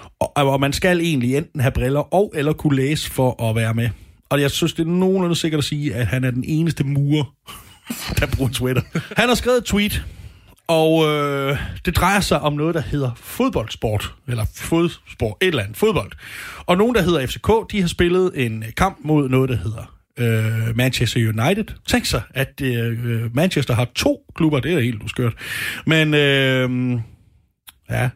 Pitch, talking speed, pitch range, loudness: 135 Hz, 185 wpm, 120-165 Hz, -19 LUFS